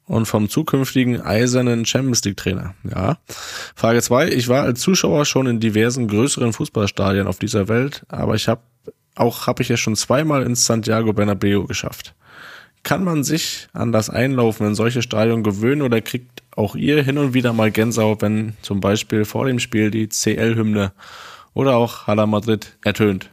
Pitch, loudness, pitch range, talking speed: 115 Hz, -18 LUFS, 105-125 Hz, 175 wpm